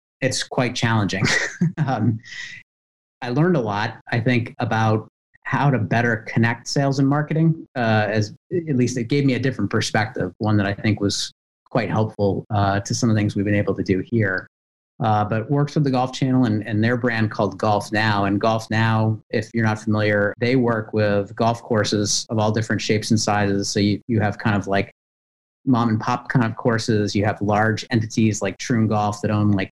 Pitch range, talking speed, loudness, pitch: 105-120 Hz, 205 wpm, -21 LUFS, 110 Hz